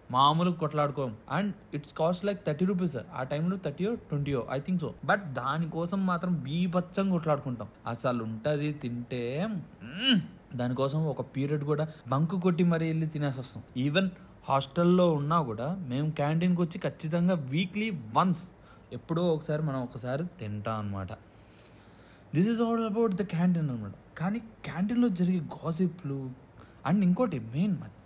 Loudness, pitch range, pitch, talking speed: -30 LUFS, 130-180 Hz, 155 Hz, 135 wpm